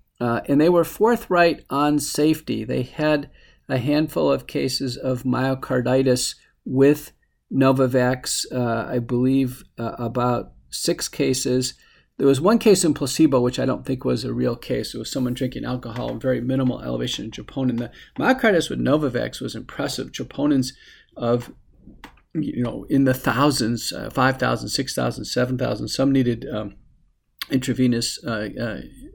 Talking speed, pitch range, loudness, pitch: 145 wpm, 120-140 Hz, -22 LUFS, 130 Hz